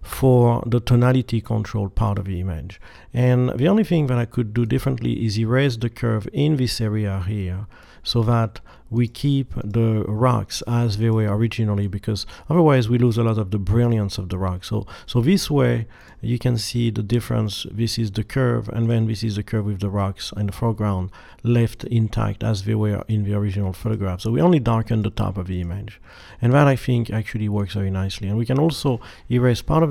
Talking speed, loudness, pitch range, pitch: 210 wpm, -21 LUFS, 105-120 Hz, 115 Hz